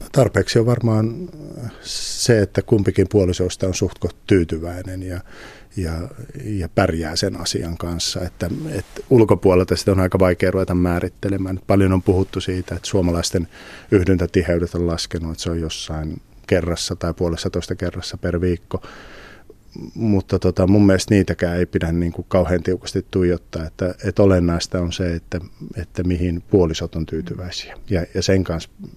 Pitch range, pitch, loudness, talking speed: 85-100 Hz, 90 Hz, -20 LUFS, 145 wpm